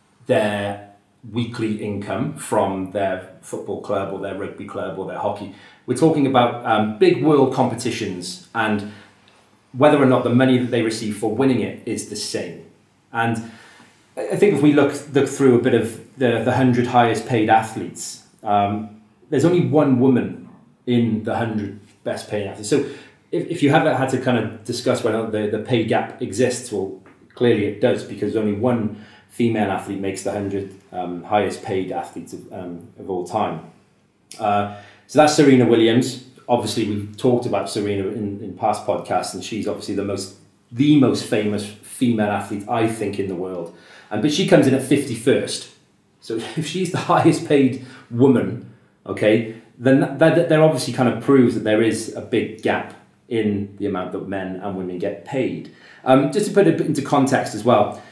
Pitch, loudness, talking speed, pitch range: 110 Hz, -20 LUFS, 185 wpm, 100-130 Hz